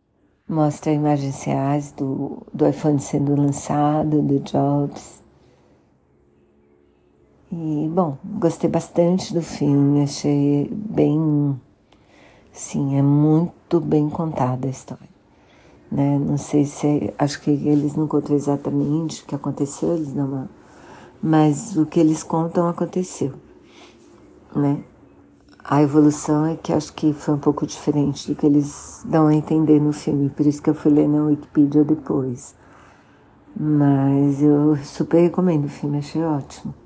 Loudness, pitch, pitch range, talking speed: -20 LUFS, 150 Hz, 140-155 Hz, 135 wpm